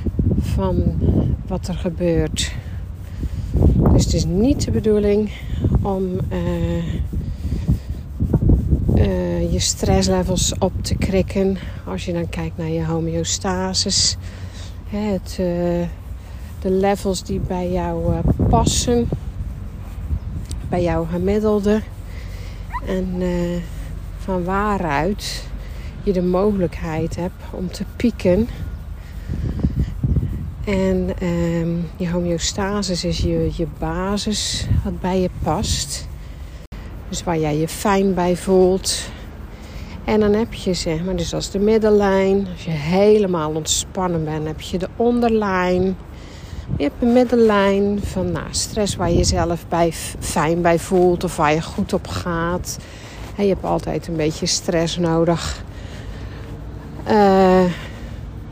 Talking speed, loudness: 120 wpm, -20 LUFS